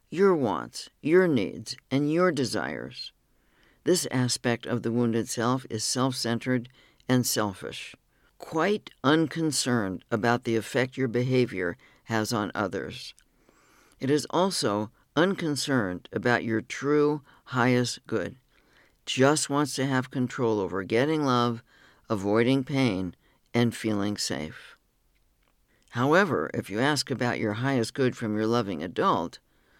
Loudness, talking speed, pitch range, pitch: -27 LUFS, 125 wpm, 115-135 Hz, 125 Hz